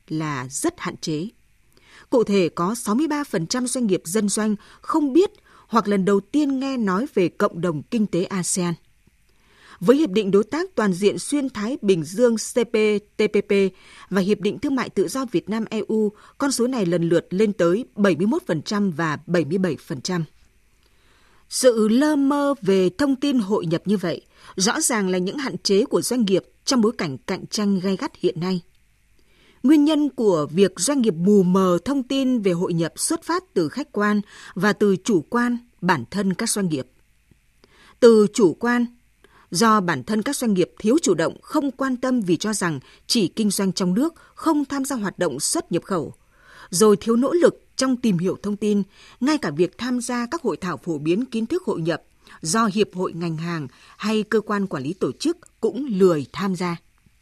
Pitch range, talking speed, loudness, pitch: 180-250 Hz, 190 wpm, -21 LUFS, 210 Hz